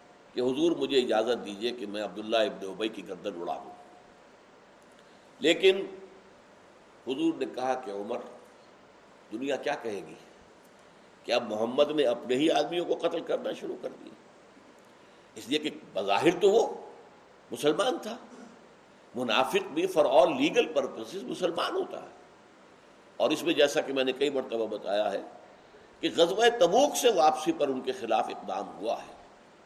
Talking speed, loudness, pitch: 155 wpm, -28 LUFS, 155 Hz